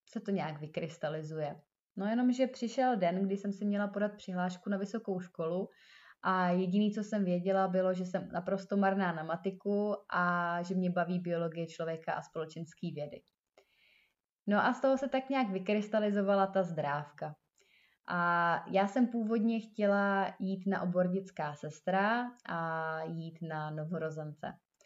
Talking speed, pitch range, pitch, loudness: 150 wpm, 165-205 Hz, 190 Hz, -34 LUFS